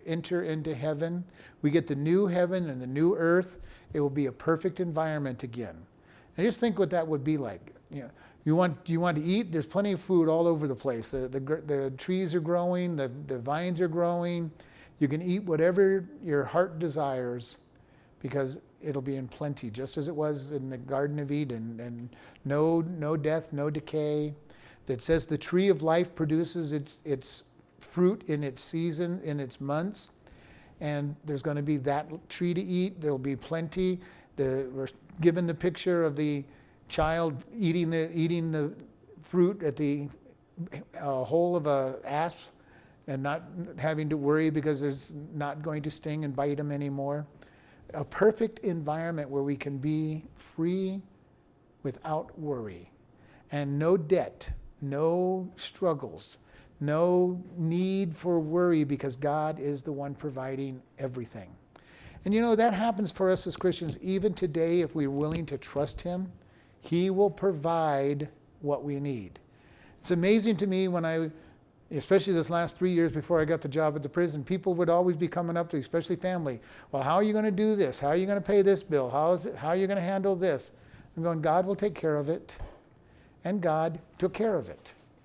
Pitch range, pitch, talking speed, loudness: 145-175 Hz, 160 Hz, 185 wpm, -30 LUFS